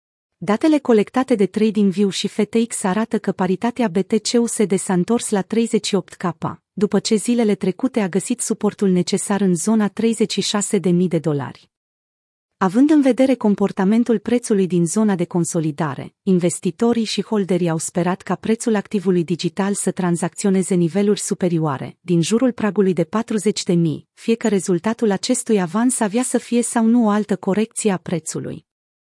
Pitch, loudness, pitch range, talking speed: 200 Hz, -19 LUFS, 180-225 Hz, 145 wpm